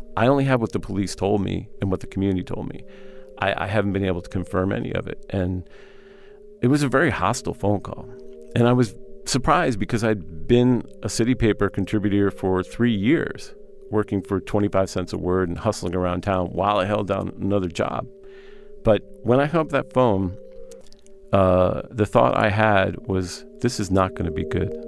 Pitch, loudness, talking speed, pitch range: 100 Hz, -22 LUFS, 195 wpm, 95-120 Hz